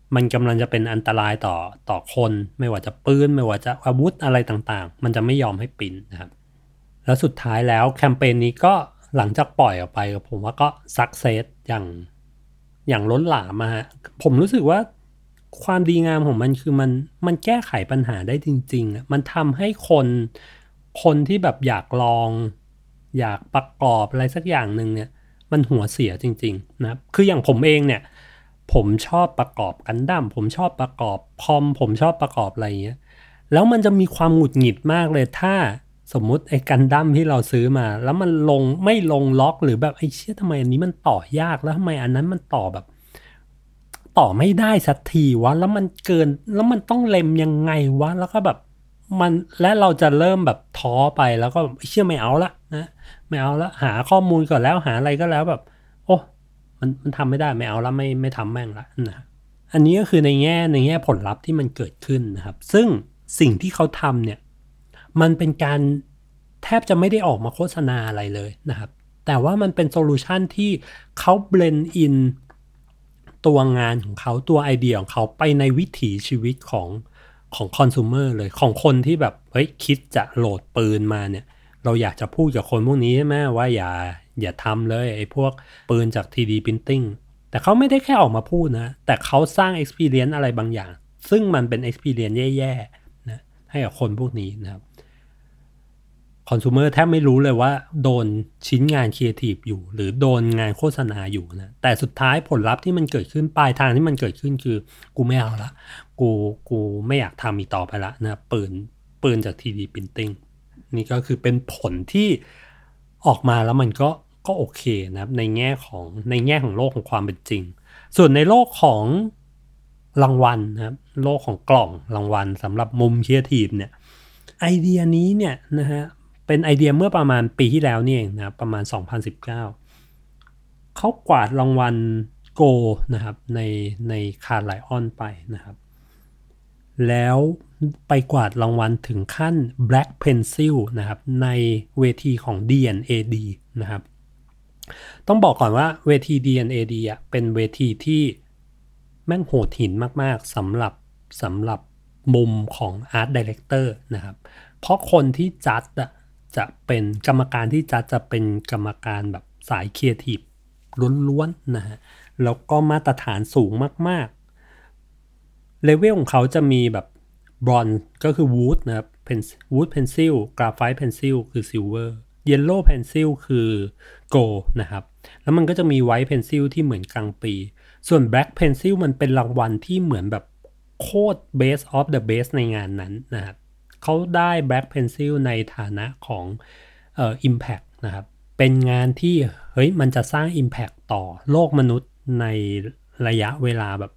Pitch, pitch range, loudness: 130 Hz, 115-150 Hz, -20 LUFS